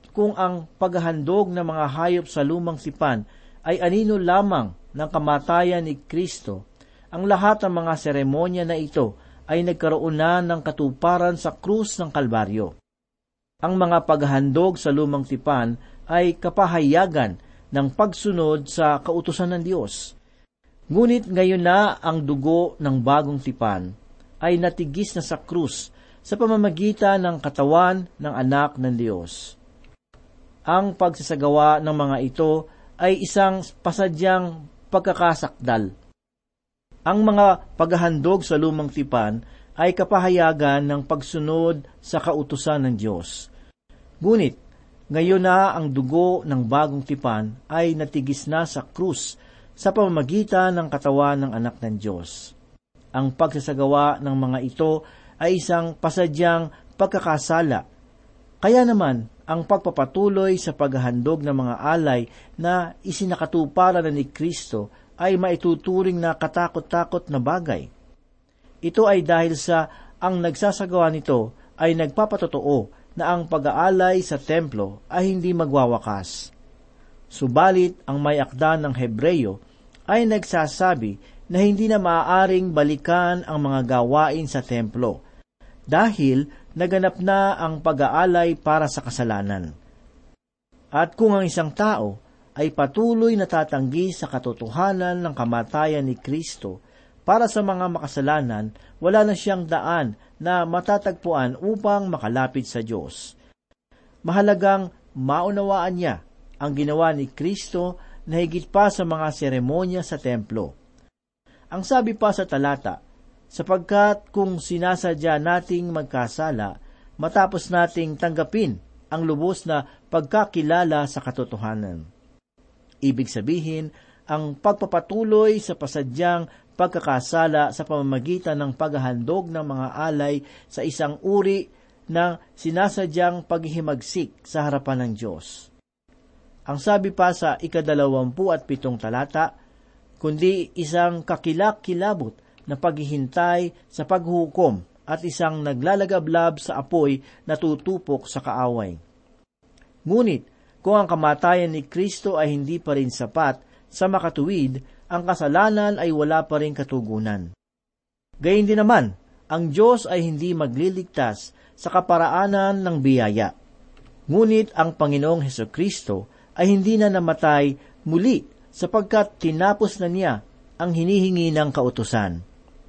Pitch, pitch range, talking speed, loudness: 160 Hz, 140-180 Hz, 120 wpm, -22 LUFS